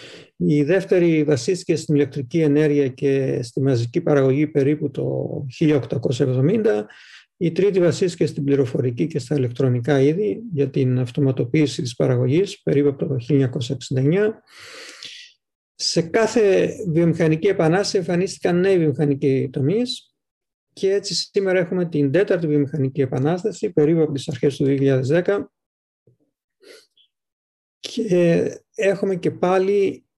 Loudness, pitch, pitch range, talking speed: -20 LUFS, 155 Hz, 140-190 Hz, 115 wpm